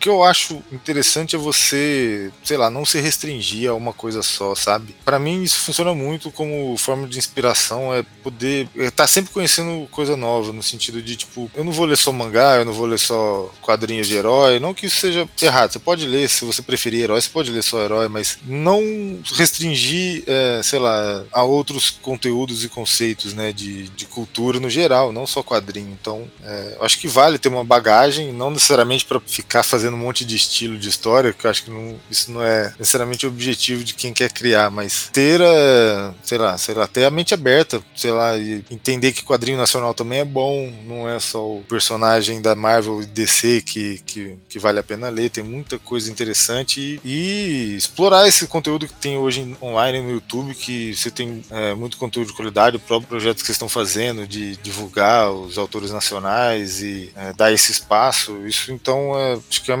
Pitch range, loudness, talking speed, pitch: 110-135 Hz, -18 LUFS, 205 wpm, 120 Hz